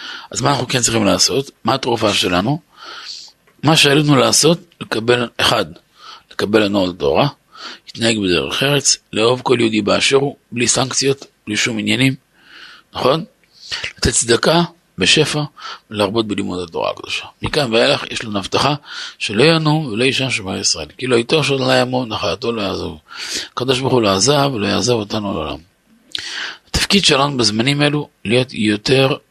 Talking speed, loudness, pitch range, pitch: 145 wpm, -16 LUFS, 110-140 Hz, 125 Hz